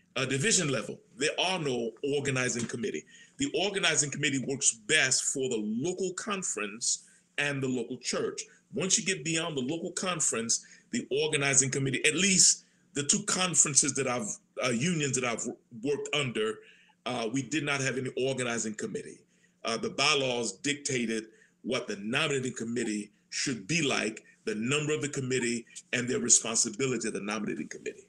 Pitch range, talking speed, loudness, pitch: 125-180 Hz, 160 wpm, -29 LUFS, 140 Hz